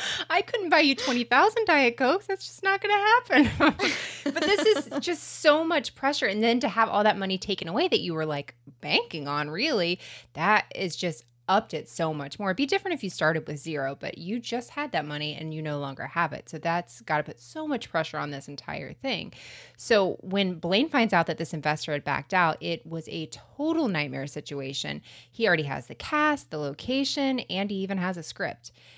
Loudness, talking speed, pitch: -26 LUFS, 220 wpm, 185 Hz